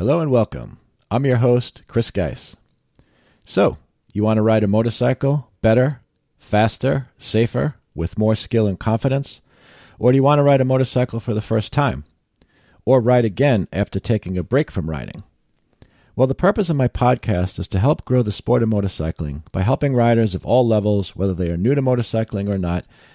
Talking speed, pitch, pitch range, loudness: 185 wpm, 115 Hz, 100-130 Hz, -19 LUFS